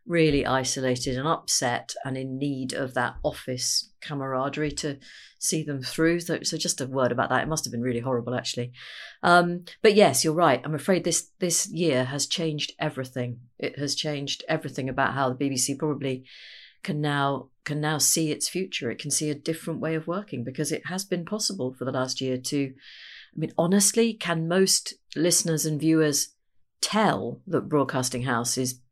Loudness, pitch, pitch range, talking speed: -26 LUFS, 145 Hz, 130-165 Hz, 185 wpm